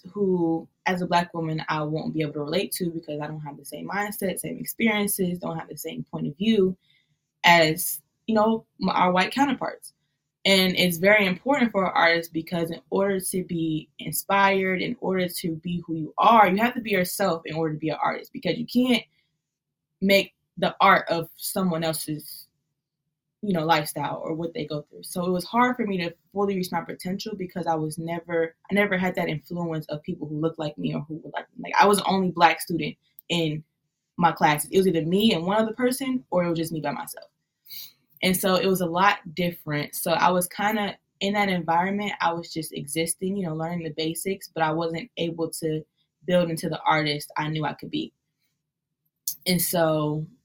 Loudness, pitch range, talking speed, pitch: -24 LUFS, 155-190 Hz, 215 wpm, 170 Hz